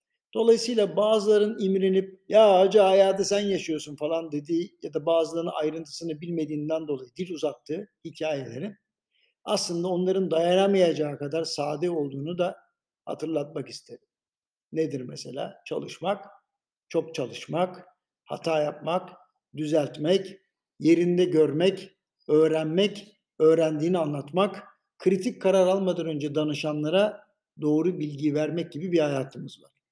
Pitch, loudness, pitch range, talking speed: 175 Hz, -26 LUFS, 155-195 Hz, 105 wpm